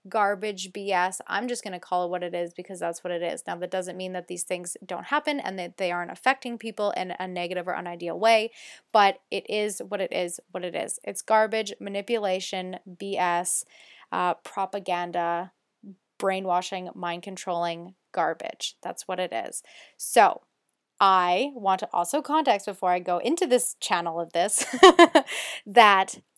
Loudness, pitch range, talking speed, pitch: -25 LUFS, 180-210 Hz, 170 wpm, 190 Hz